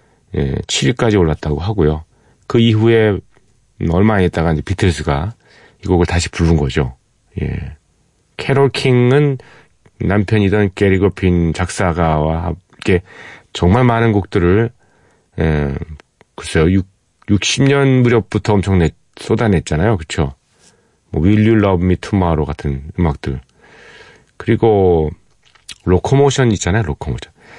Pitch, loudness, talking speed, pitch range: 95 Hz, -15 LUFS, 250 characters per minute, 80-110 Hz